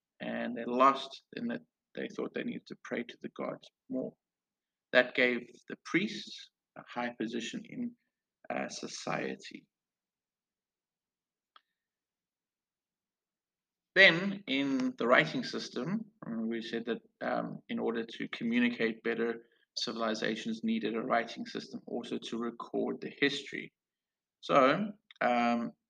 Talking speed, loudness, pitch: 120 wpm, -32 LUFS, 135 Hz